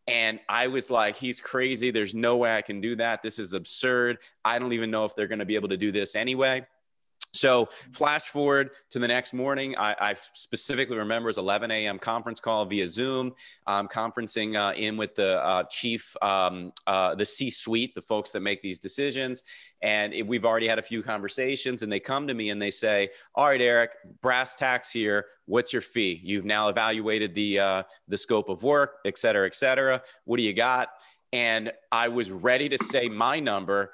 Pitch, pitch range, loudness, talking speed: 115 Hz, 105-125 Hz, -26 LUFS, 210 wpm